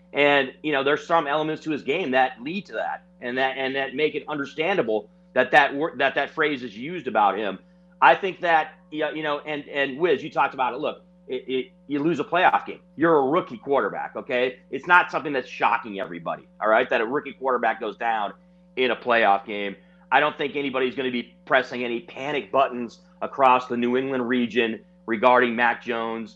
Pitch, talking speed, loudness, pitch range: 135 Hz, 205 wpm, -23 LUFS, 125-155 Hz